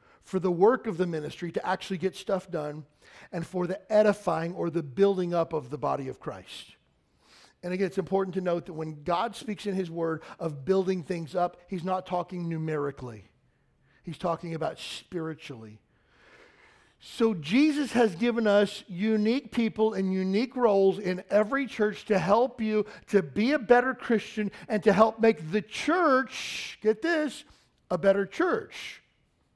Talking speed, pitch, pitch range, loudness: 165 wpm, 195 Hz, 175-220 Hz, -28 LUFS